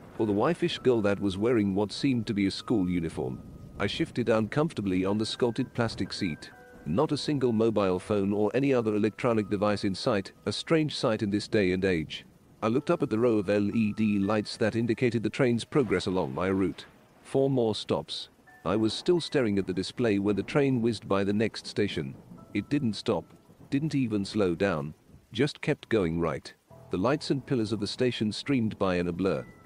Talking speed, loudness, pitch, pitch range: 200 wpm, -28 LUFS, 110 Hz, 100-125 Hz